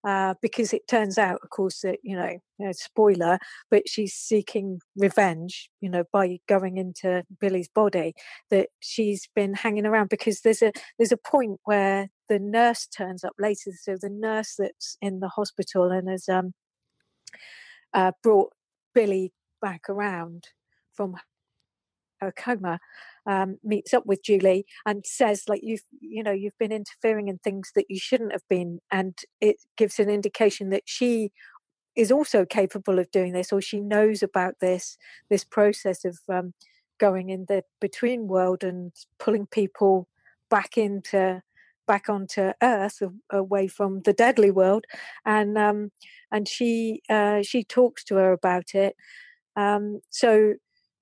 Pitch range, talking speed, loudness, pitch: 190-215 Hz, 155 wpm, -25 LUFS, 200 Hz